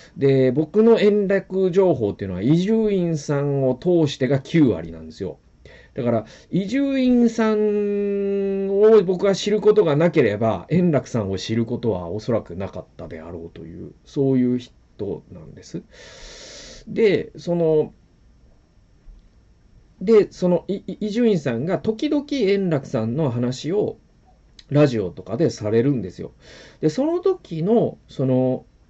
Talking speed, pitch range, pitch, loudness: 260 characters per minute, 120-205 Hz, 160 Hz, -20 LUFS